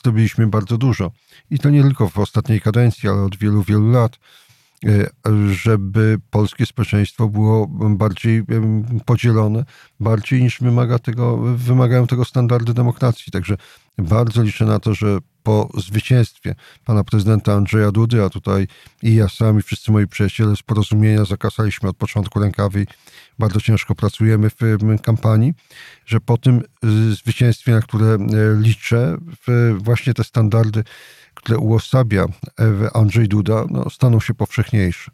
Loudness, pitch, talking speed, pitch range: -17 LUFS, 110 Hz, 135 wpm, 105-120 Hz